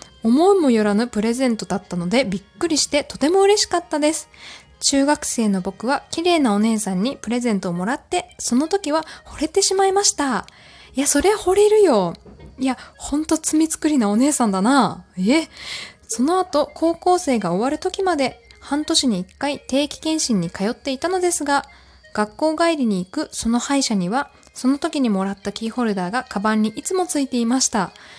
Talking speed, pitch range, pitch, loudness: 360 characters per minute, 225-315 Hz, 275 Hz, -20 LUFS